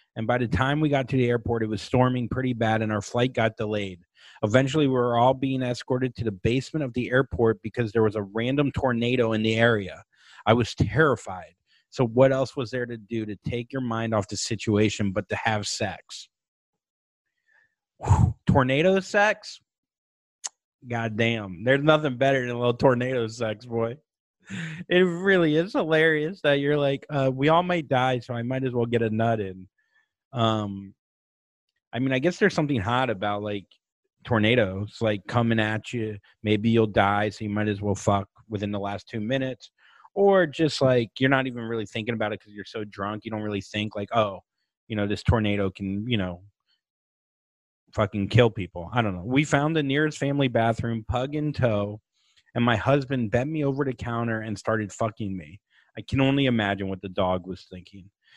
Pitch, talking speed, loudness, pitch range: 115 Hz, 190 wpm, -25 LUFS, 105-135 Hz